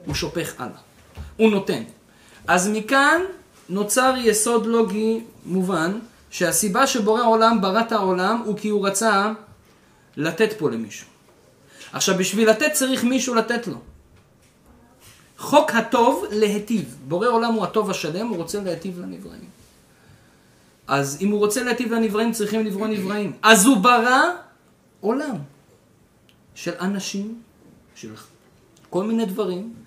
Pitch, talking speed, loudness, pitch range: 215 Hz, 125 wpm, -20 LUFS, 190-230 Hz